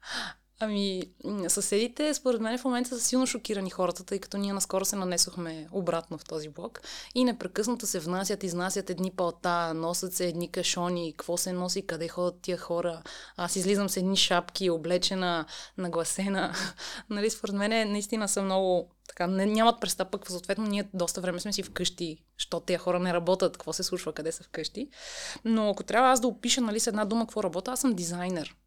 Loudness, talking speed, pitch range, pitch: -29 LUFS, 180 wpm, 175-210 Hz, 185 Hz